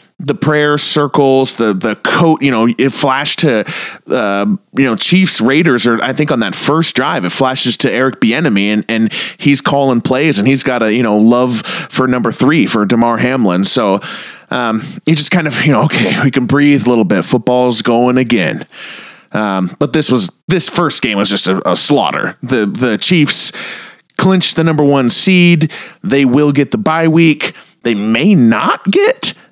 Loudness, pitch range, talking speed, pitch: -11 LUFS, 120-160 Hz, 190 wpm, 140 Hz